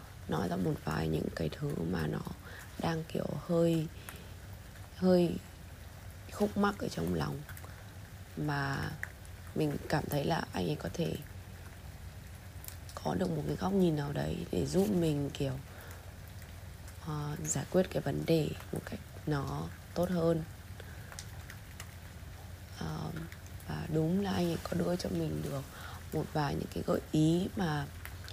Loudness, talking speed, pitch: -34 LUFS, 145 wpm, 95 Hz